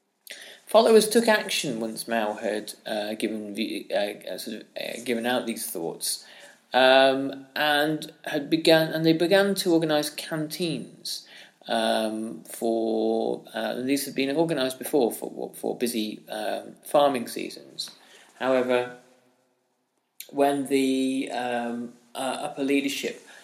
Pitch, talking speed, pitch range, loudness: 130 Hz, 125 wpm, 115-150 Hz, -25 LUFS